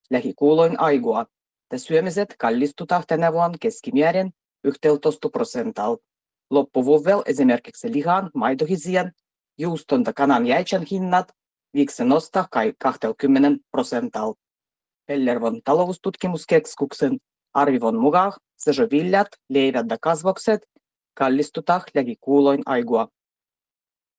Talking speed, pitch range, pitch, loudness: 90 wpm, 140-185 Hz, 160 Hz, -21 LUFS